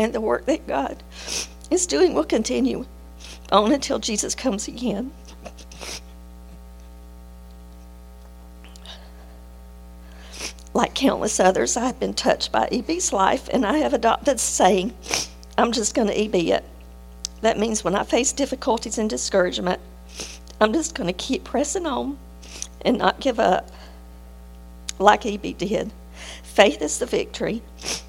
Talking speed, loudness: 130 wpm, -22 LUFS